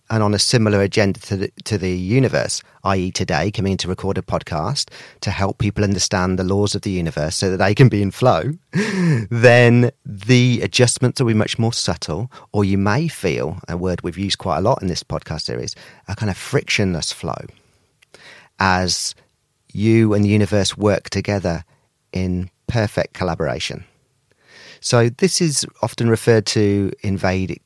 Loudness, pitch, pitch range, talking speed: -18 LUFS, 100 Hz, 95-115 Hz, 175 wpm